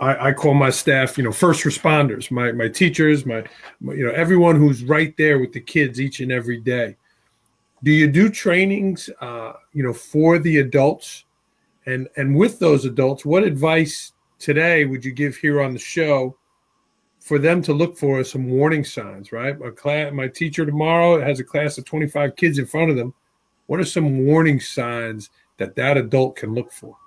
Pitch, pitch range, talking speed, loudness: 145 Hz, 130-160 Hz, 195 wpm, -18 LUFS